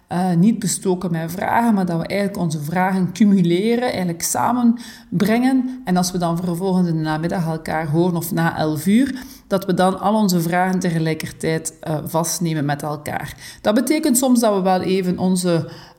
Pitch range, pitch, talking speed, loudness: 165-200 Hz, 180 Hz, 175 wpm, -19 LUFS